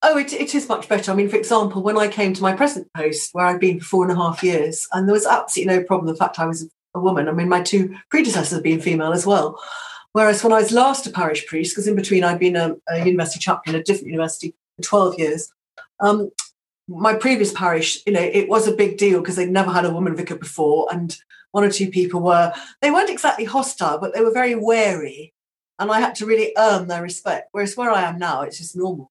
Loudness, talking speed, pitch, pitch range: -19 LUFS, 250 wpm, 190 Hz, 170-215 Hz